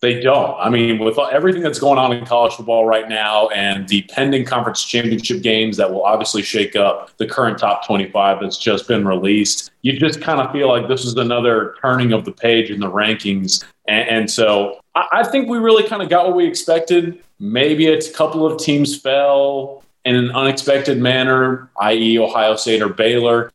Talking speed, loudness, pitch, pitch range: 195 wpm, -16 LUFS, 120 Hz, 110-140 Hz